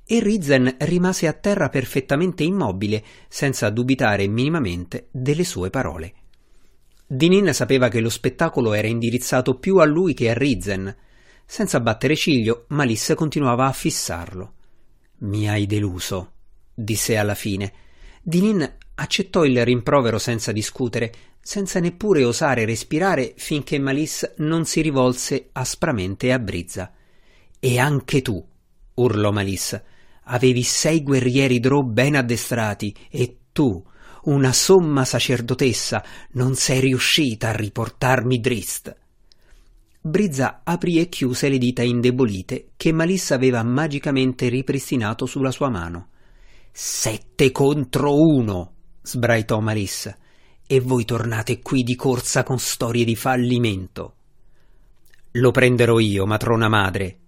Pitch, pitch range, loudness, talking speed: 125 Hz, 110-140 Hz, -20 LUFS, 120 wpm